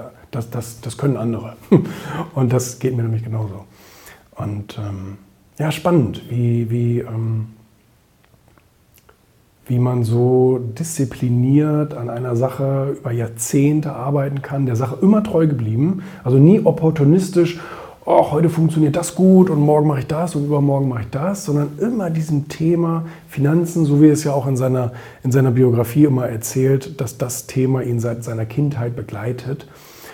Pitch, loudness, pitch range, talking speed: 135 Hz, -18 LUFS, 120-150 Hz, 155 wpm